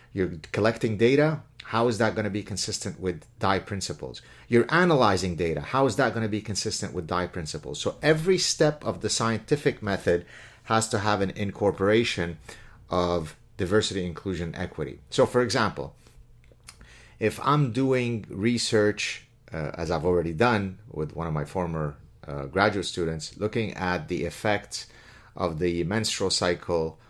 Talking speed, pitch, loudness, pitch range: 155 wpm, 105 Hz, -26 LUFS, 90-120 Hz